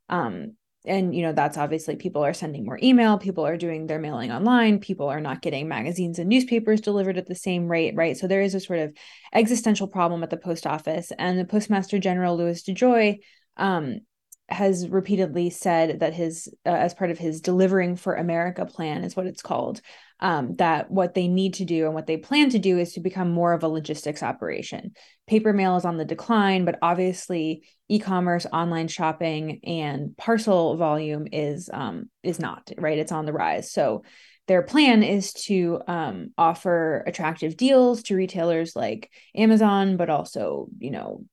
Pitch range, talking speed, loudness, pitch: 165-195 Hz, 185 wpm, -24 LUFS, 180 Hz